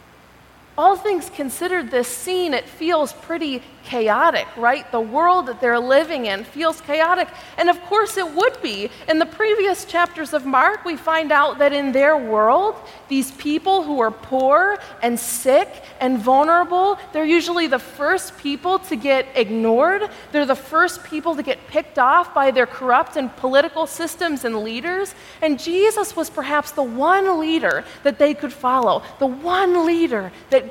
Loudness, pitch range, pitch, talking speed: -19 LUFS, 265-345 Hz, 305 Hz, 165 wpm